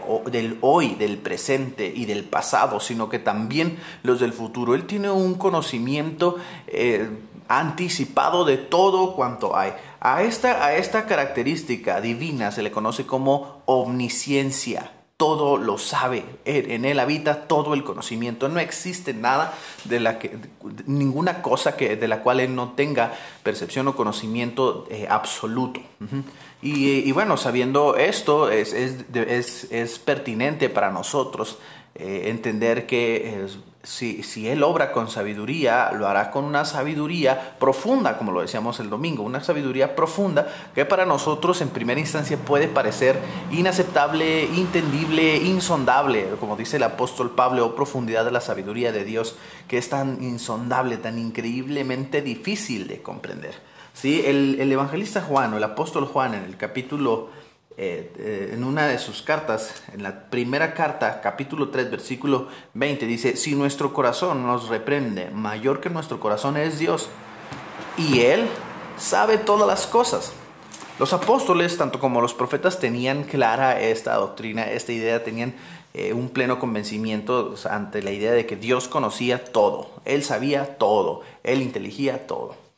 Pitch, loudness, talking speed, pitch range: 135 Hz, -23 LUFS, 155 wpm, 120-155 Hz